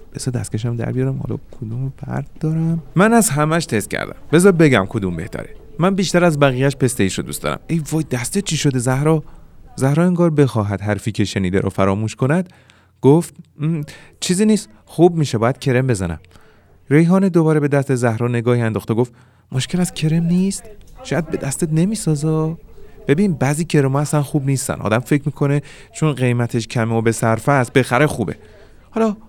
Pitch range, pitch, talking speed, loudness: 115-160 Hz, 140 Hz, 170 wpm, -18 LUFS